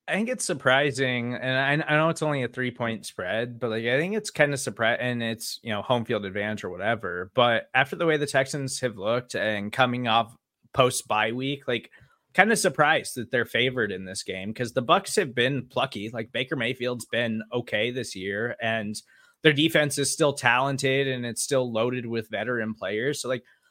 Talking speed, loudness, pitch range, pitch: 210 wpm, -25 LUFS, 115-140 Hz, 125 Hz